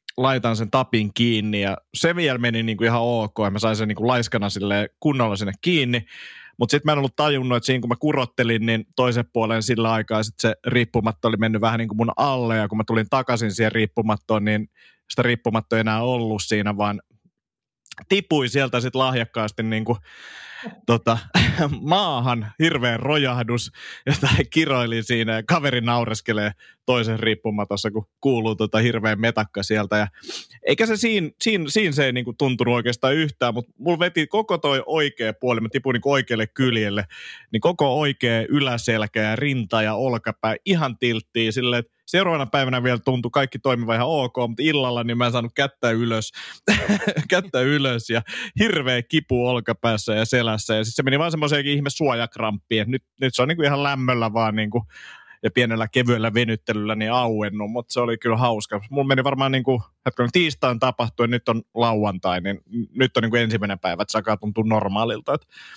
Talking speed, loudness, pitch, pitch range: 180 wpm, -21 LUFS, 120 Hz, 110-130 Hz